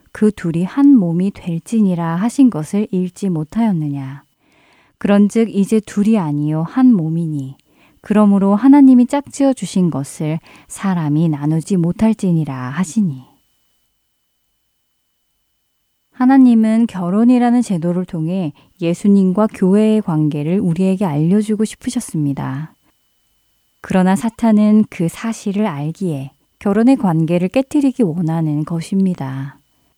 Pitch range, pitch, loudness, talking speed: 160-220 Hz, 190 Hz, -15 LUFS, 265 characters per minute